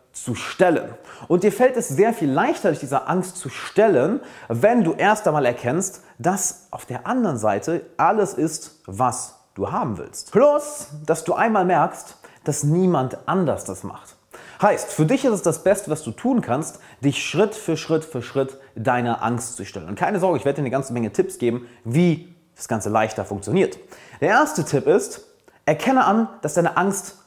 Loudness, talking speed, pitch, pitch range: -21 LUFS, 190 wpm, 160 Hz, 125-195 Hz